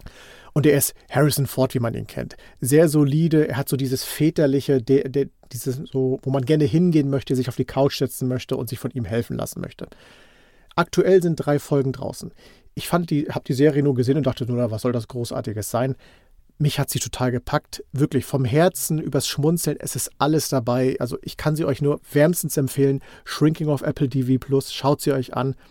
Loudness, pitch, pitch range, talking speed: -22 LUFS, 140 Hz, 130-150 Hz, 210 wpm